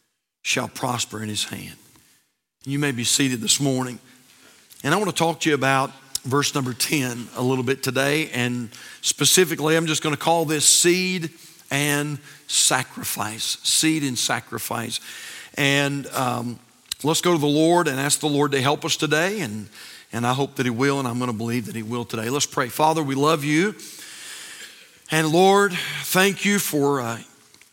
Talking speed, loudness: 180 wpm, -21 LUFS